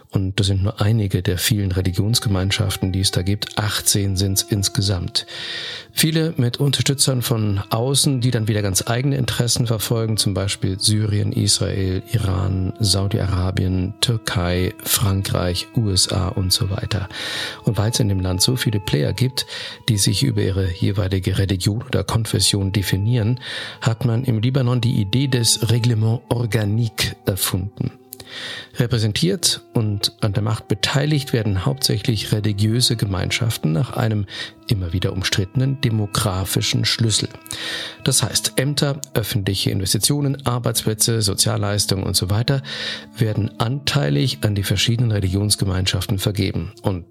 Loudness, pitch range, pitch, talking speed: -20 LUFS, 100-125 Hz, 110 Hz, 130 wpm